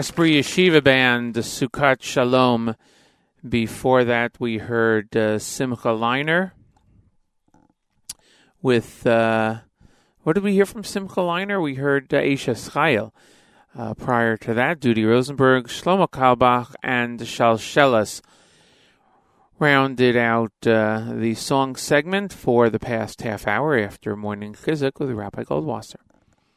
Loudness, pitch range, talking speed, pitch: -20 LUFS, 115-140 Hz, 120 wpm, 125 Hz